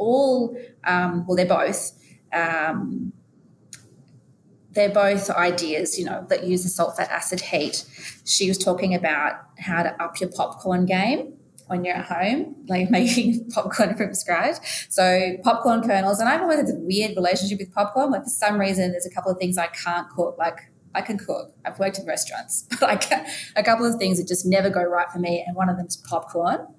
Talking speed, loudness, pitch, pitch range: 195 wpm, -23 LUFS, 190 Hz, 180-230 Hz